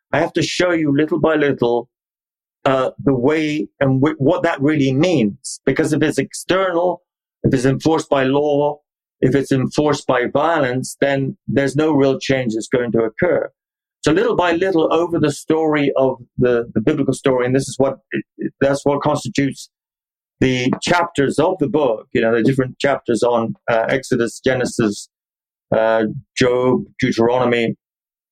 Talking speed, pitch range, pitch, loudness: 165 wpm, 125-150 Hz, 135 Hz, -18 LUFS